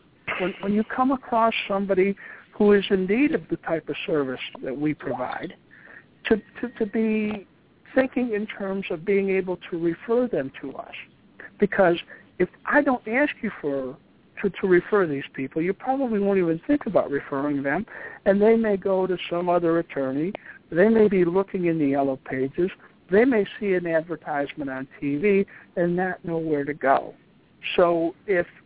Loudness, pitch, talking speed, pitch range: -24 LUFS, 190 Hz, 180 wpm, 165-210 Hz